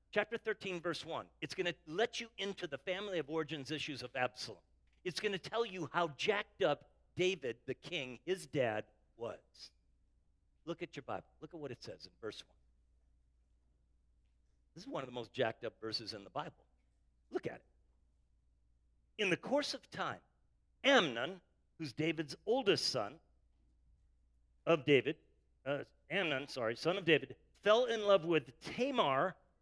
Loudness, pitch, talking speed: -37 LUFS, 145 Hz, 165 wpm